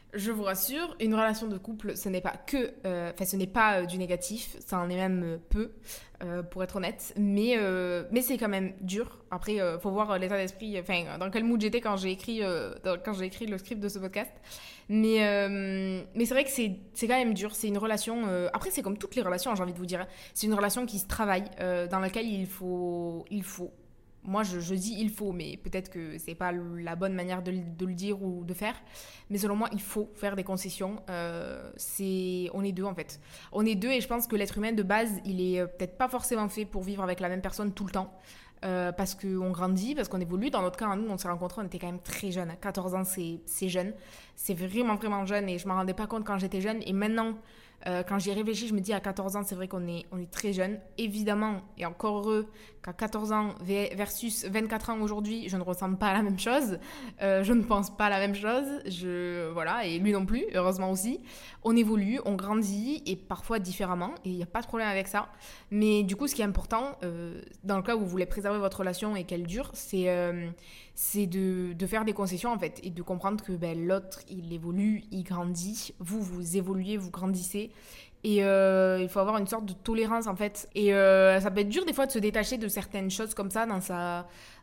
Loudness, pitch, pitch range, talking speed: -31 LUFS, 195 Hz, 185-215 Hz, 245 wpm